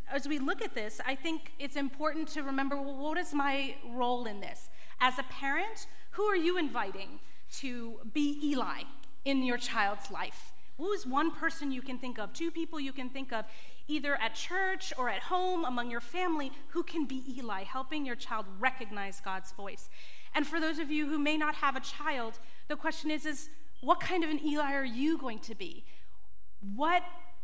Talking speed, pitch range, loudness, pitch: 200 wpm, 250-315 Hz, -34 LUFS, 280 Hz